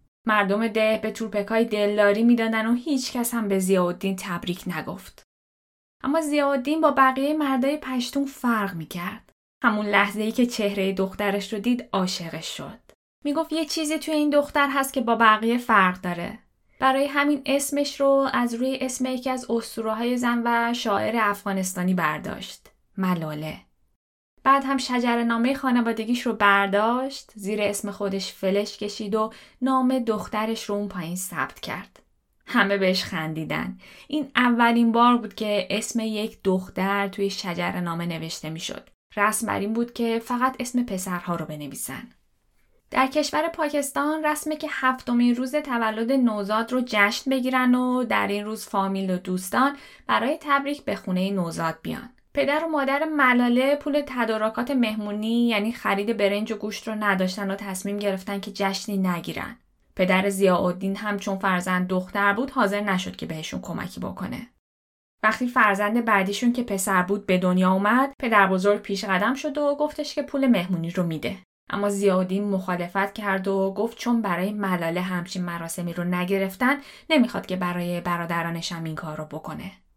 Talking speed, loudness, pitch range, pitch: 160 wpm, -24 LUFS, 190-255 Hz, 215 Hz